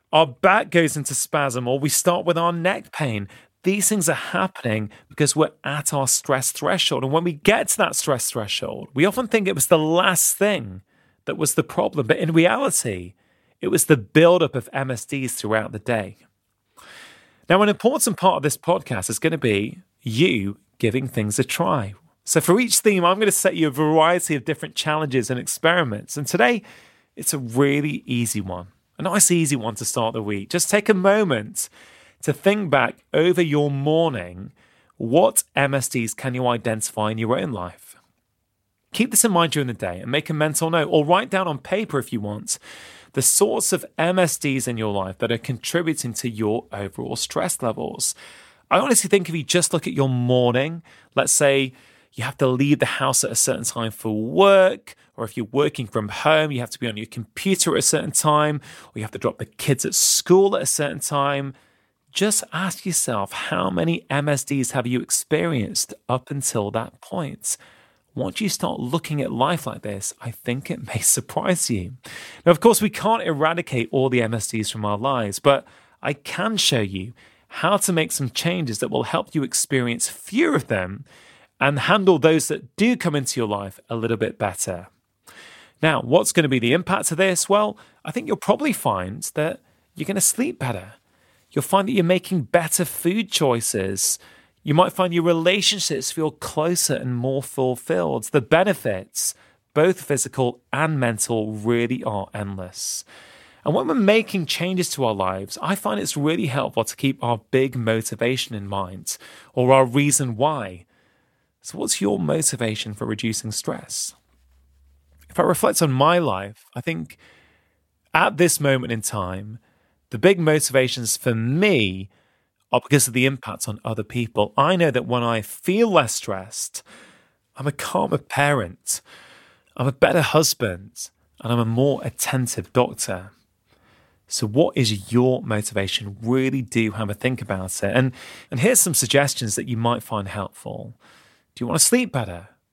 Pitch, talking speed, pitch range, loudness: 130 Hz, 180 wpm, 110-165 Hz, -21 LUFS